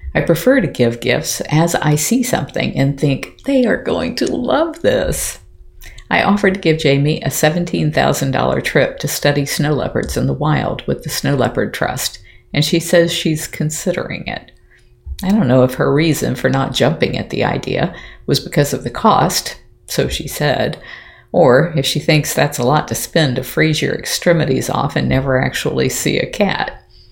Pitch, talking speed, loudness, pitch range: 155 Hz, 185 wpm, -16 LUFS, 135-175 Hz